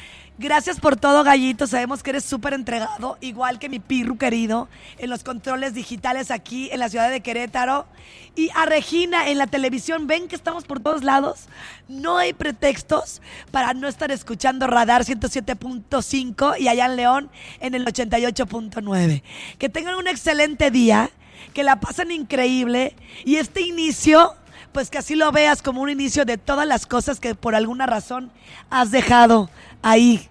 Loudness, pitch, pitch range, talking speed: -20 LUFS, 265 Hz, 245-290 Hz, 165 wpm